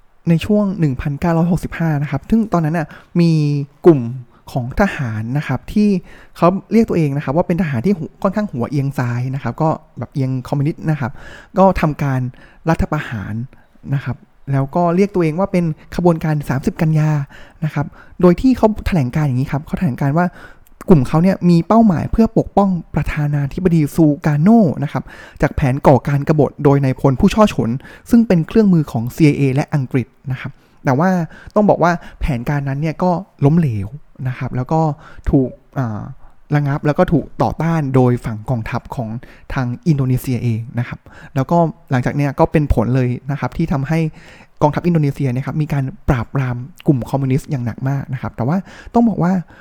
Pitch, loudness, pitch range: 150 Hz, -17 LUFS, 130-175 Hz